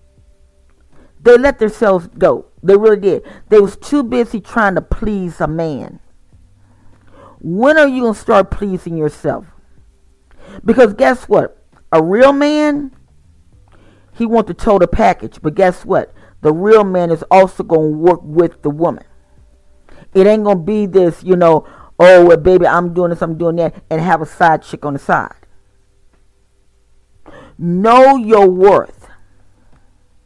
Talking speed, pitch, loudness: 145 wpm, 170 Hz, -12 LUFS